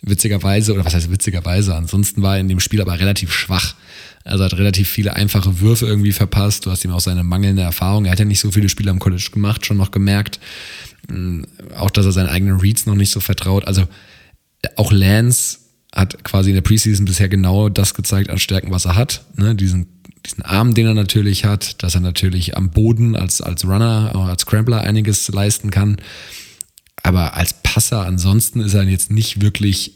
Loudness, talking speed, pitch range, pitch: -16 LUFS, 200 wpm, 95-105 Hz, 100 Hz